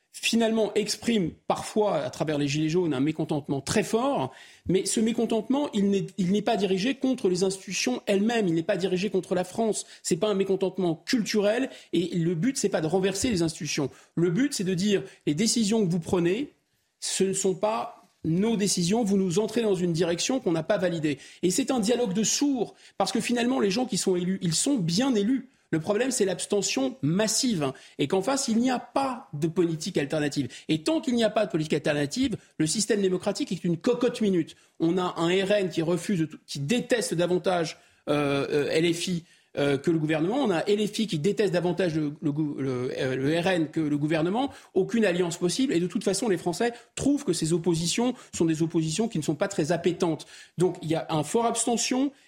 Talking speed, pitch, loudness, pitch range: 210 wpm, 190 Hz, -26 LUFS, 165-225 Hz